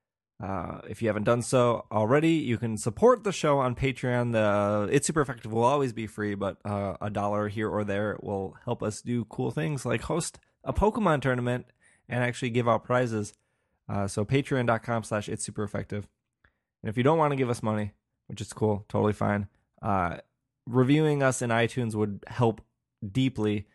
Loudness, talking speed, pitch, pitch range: -28 LUFS, 185 wpm, 115 Hz, 105-130 Hz